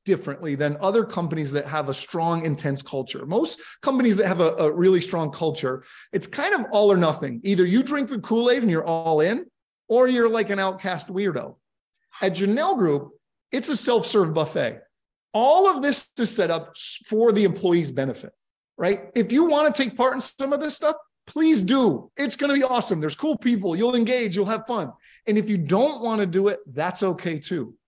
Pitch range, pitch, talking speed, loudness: 165-245 Hz, 200 Hz, 205 wpm, -22 LUFS